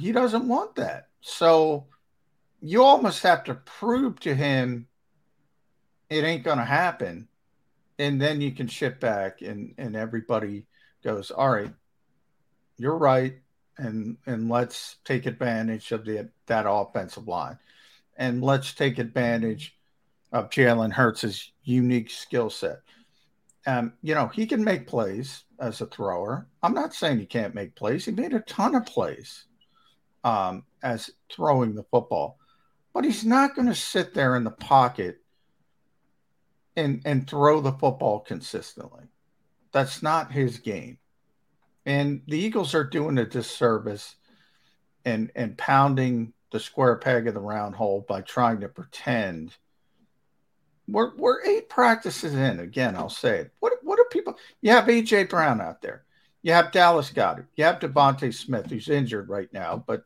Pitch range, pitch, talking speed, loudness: 120-175 Hz, 135 Hz, 150 wpm, -25 LUFS